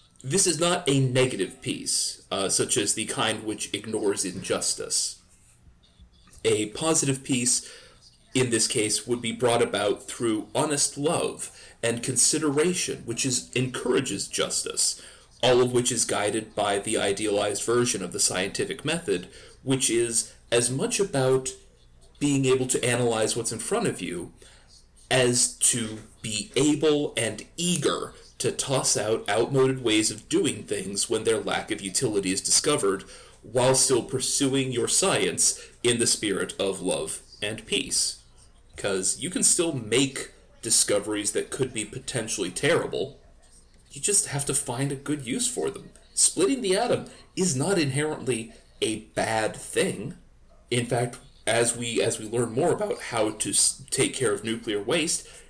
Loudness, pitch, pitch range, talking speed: -25 LUFS, 125 Hz, 115-145 Hz, 150 wpm